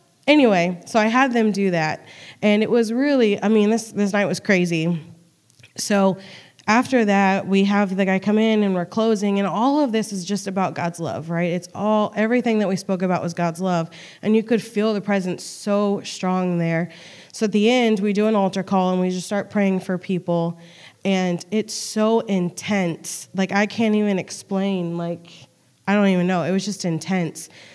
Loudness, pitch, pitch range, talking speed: -21 LUFS, 195 Hz, 175-210 Hz, 200 wpm